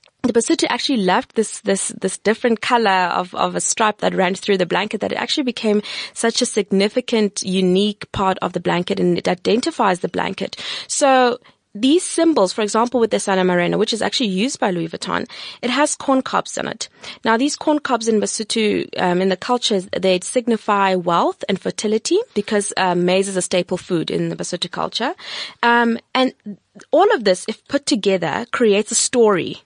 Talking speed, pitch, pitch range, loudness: 190 wpm, 215 Hz, 190-245 Hz, -18 LUFS